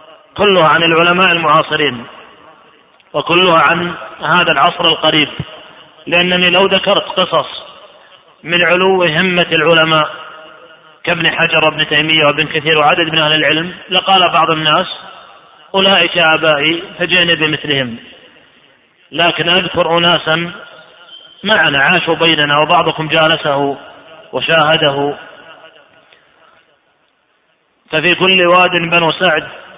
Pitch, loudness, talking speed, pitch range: 160 Hz, -11 LUFS, 95 wpm, 155-175 Hz